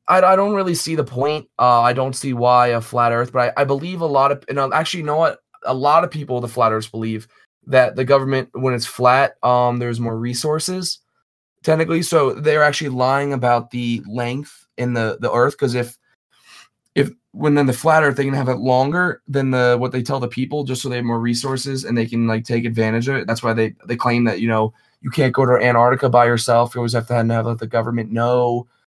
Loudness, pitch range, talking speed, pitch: -18 LUFS, 120-140 Hz, 240 wpm, 125 Hz